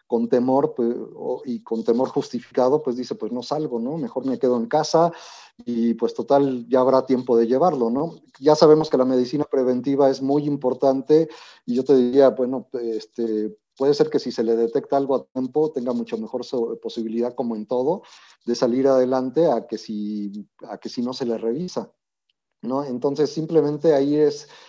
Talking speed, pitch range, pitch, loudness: 185 wpm, 120-140 Hz, 130 Hz, -22 LUFS